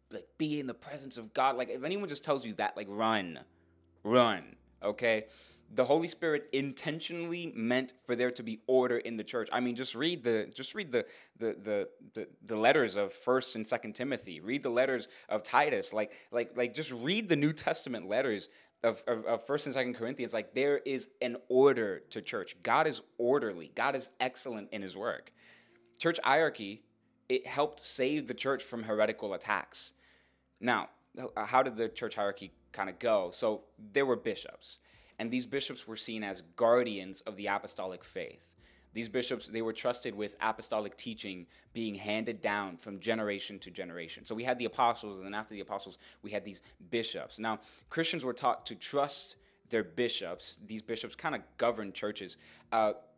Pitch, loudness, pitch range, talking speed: 115 Hz, -34 LUFS, 105-130 Hz, 185 wpm